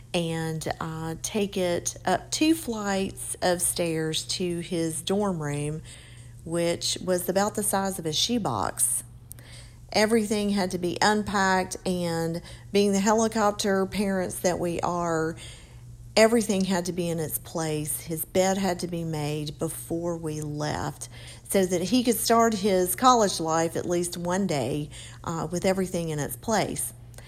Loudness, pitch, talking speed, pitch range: -26 LUFS, 175 Hz, 150 wpm, 150-195 Hz